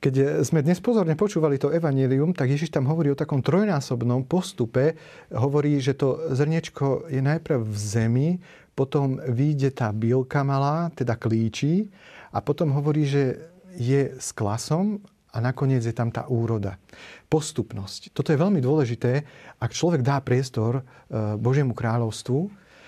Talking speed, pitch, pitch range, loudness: 140 wpm, 140 Hz, 125-155 Hz, -24 LUFS